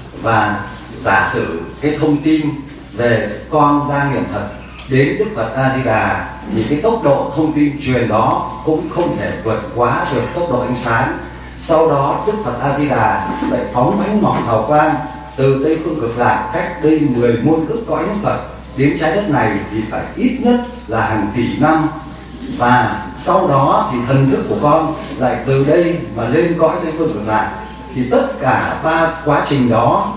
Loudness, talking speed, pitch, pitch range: -15 LUFS, 195 wpm, 135 Hz, 115-155 Hz